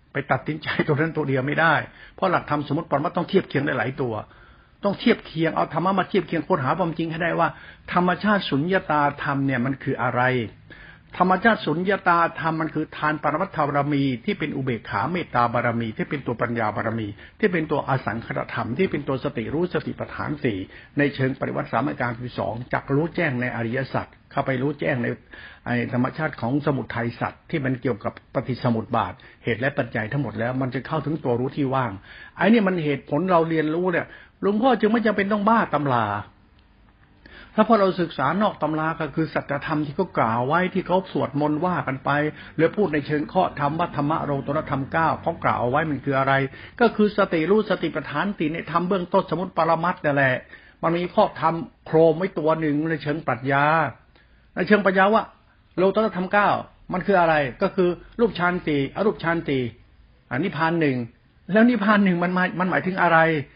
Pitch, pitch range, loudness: 150 Hz, 130-175 Hz, -23 LUFS